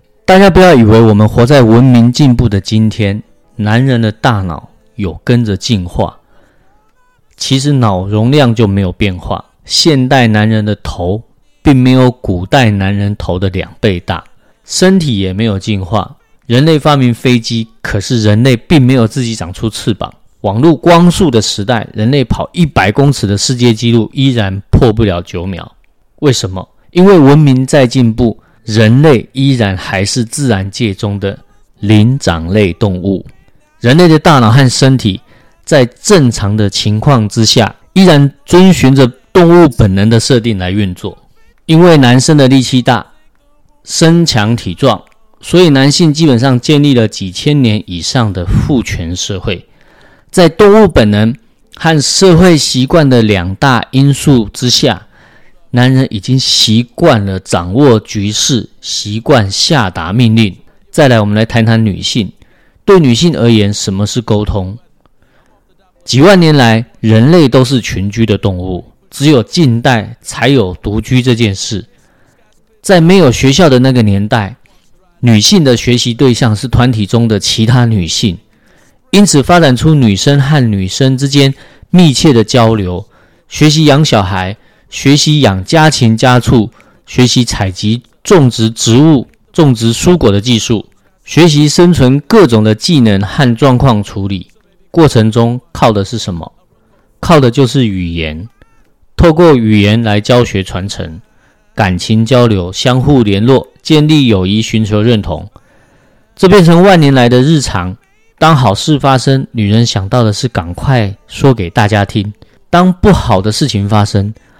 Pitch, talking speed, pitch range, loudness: 120 Hz, 225 characters per minute, 105-140 Hz, -9 LUFS